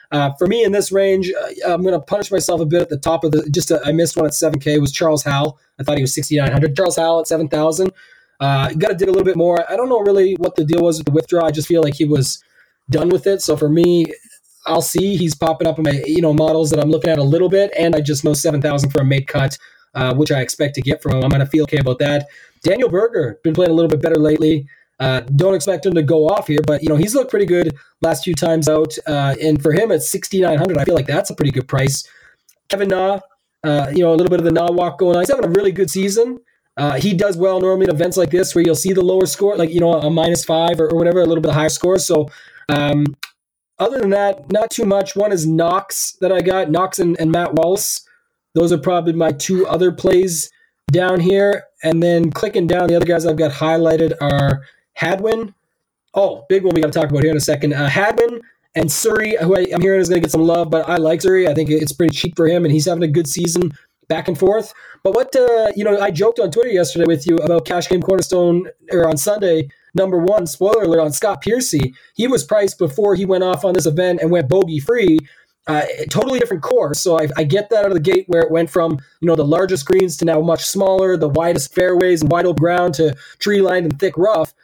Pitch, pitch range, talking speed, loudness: 170 Hz, 155-190 Hz, 260 wpm, -16 LUFS